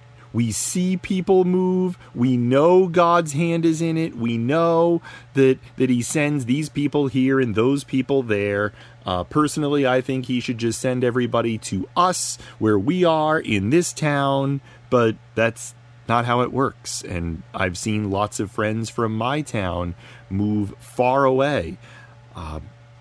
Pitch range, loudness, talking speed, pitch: 115-145 Hz, -21 LUFS, 155 wpm, 125 Hz